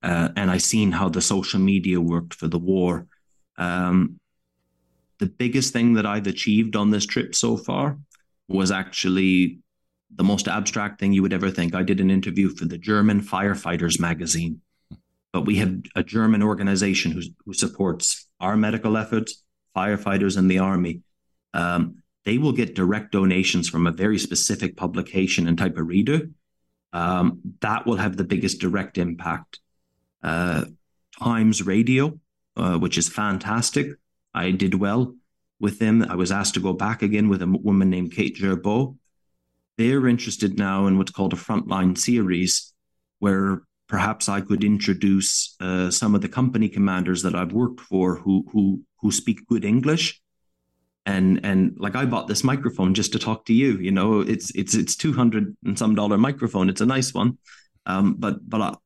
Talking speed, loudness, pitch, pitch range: 170 wpm, -22 LUFS, 95 Hz, 90-105 Hz